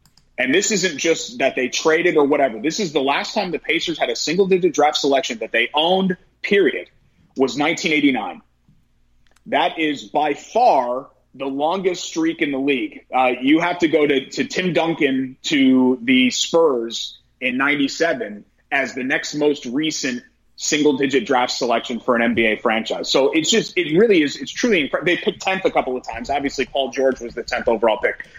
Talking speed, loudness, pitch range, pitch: 185 wpm, -19 LUFS, 135-185 Hz, 150 Hz